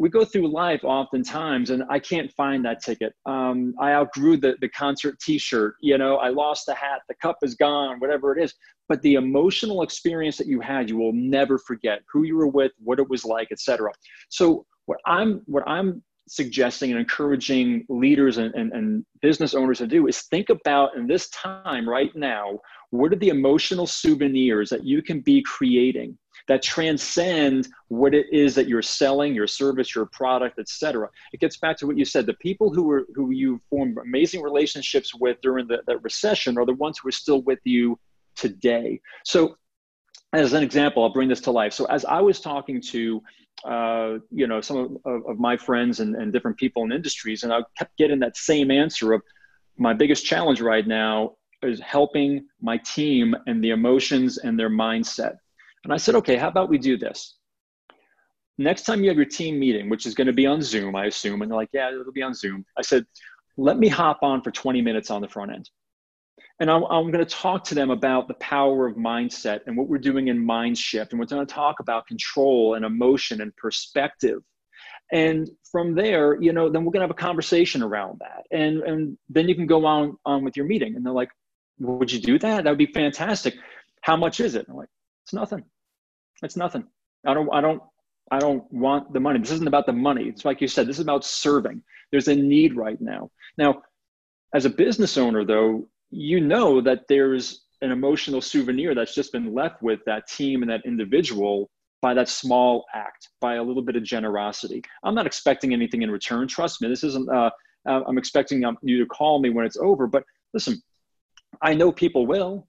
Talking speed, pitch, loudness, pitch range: 205 wpm, 140 Hz, -22 LUFS, 120-155 Hz